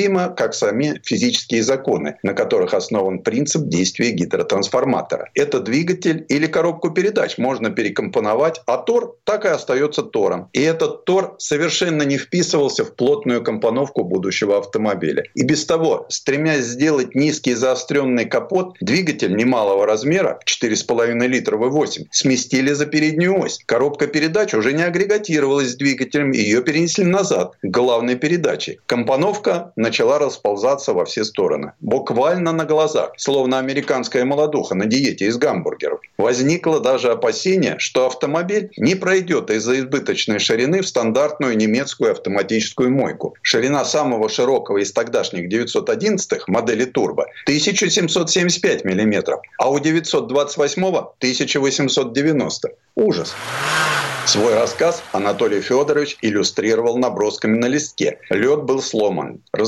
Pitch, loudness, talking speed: 165 Hz, -18 LUFS, 125 wpm